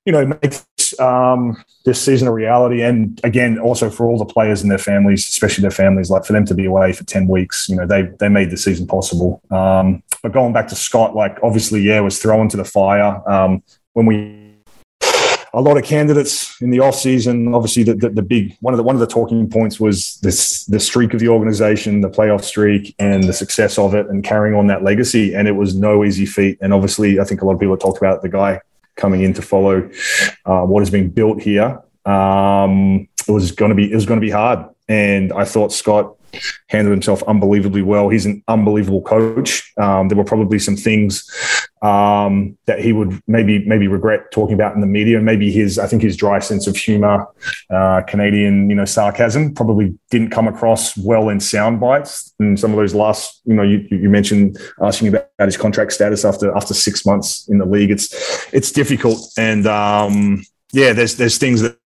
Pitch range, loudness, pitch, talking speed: 100-115 Hz, -15 LUFS, 105 Hz, 215 wpm